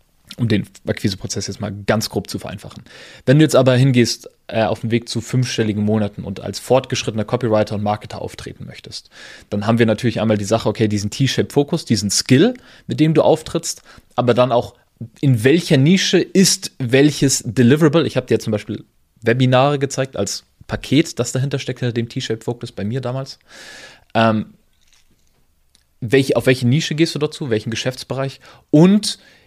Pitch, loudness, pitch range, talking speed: 120 Hz, -17 LUFS, 110-135 Hz, 170 wpm